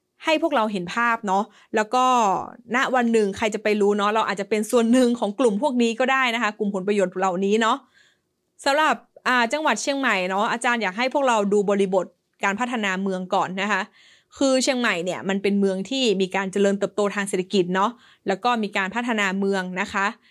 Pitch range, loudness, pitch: 195-245 Hz, -22 LUFS, 210 Hz